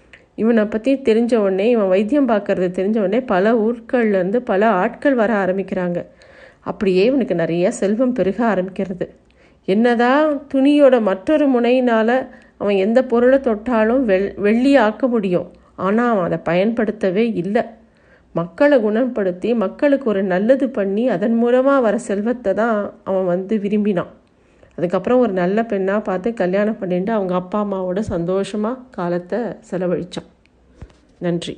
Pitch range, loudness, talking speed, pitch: 190-245 Hz, -18 LUFS, 120 wpm, 210 Hz